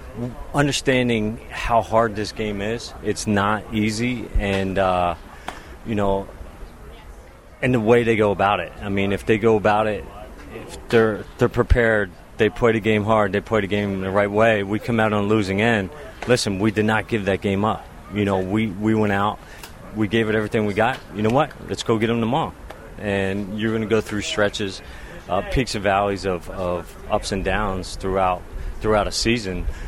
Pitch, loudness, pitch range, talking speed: 105 Hz, -21 LUFS, 95-110 Hz, 200 wpm